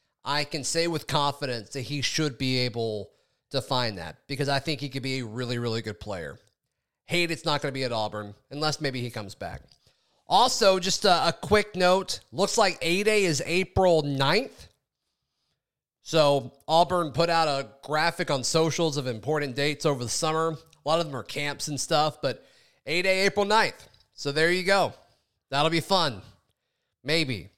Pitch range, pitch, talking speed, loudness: 130-165 Hz, 145 Hz, 185 wpm, -26 LUFS